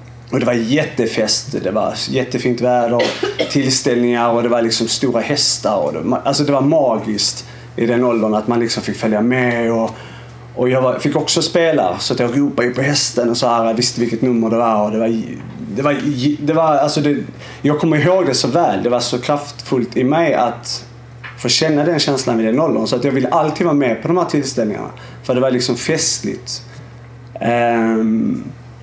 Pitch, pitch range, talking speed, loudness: 120 Hz, 115-135 Hz, 185 wpm, -16 LUFS